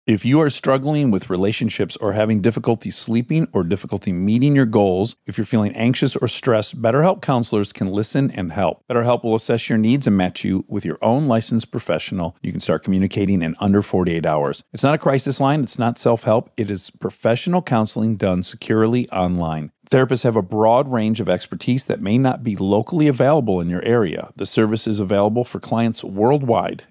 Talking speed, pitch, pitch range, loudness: 195 wpm, 115 Hz, 100-130 Hz, -19 LUFS